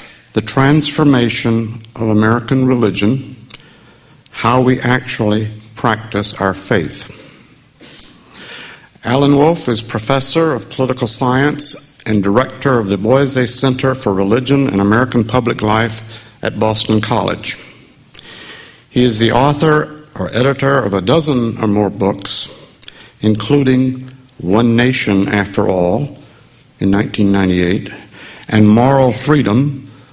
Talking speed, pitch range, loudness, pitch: 110 wpm, 110-135 Hz, -13 LUFS, 120 Hz